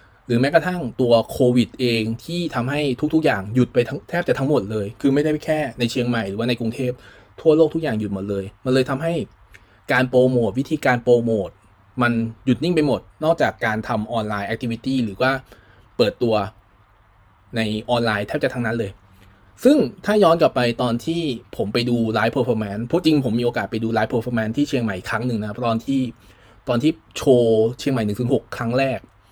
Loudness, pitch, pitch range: -21 LUFS, 120 Hz, 110-135 Hz